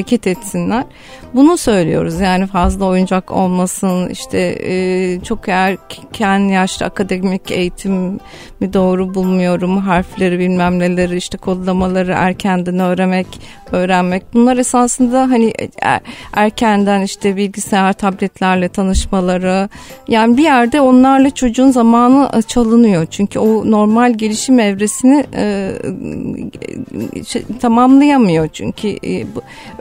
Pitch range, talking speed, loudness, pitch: 185-230 Hz, 105 wpm, -13 LUFS, 195 Hz